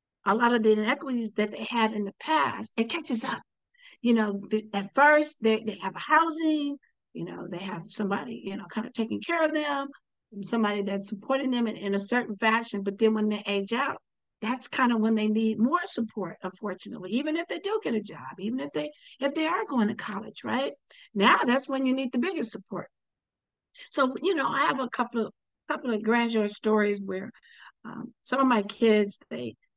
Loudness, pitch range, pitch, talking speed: -27 LUFS, 210-265 Hz, 225 Hz, 210 wpm